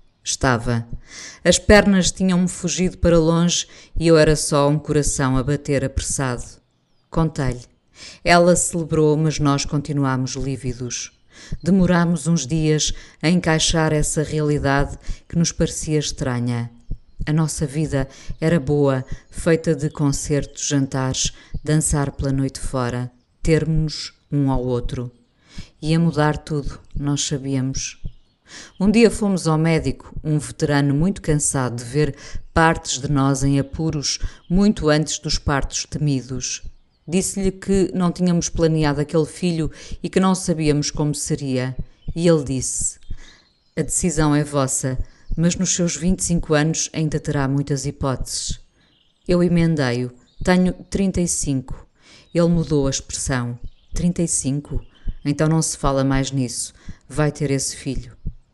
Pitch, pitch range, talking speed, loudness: 150 Hz, 135-165 Hz, 130 wpm, -20 LUFS